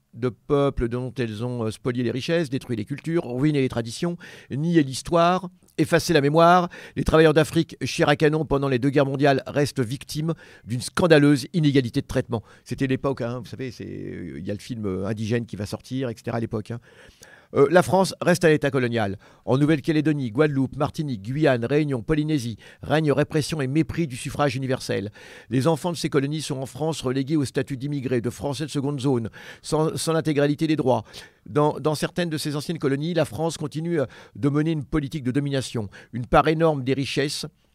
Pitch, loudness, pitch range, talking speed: 140 Hz, -23 LUFS, 125-155 Hz, 190 wpm